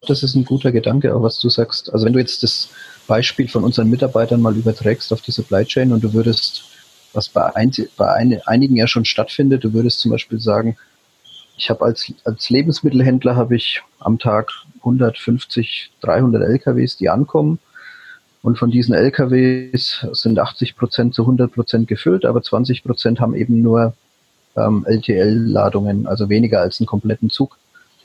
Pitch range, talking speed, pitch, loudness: 110-130 Hz, 170 wpm, 120 Hz, -16 LUFS